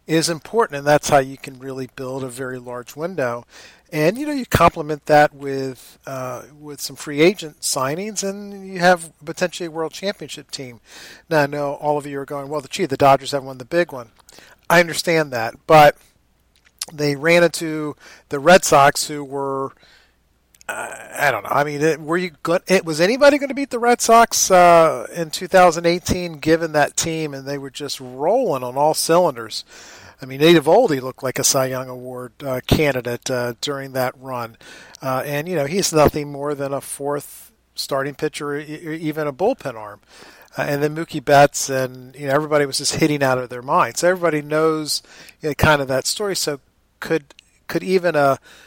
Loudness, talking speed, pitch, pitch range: -19 LUFS, 195 wpm, 145 Hz, 135-165 Hz